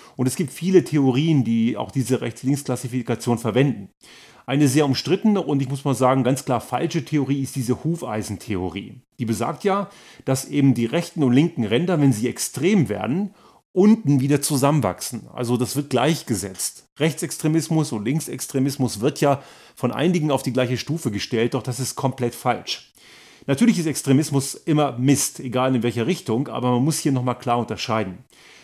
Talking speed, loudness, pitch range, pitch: 165 wpm, -22 LUFS, 125-150 Hz, 135 Hz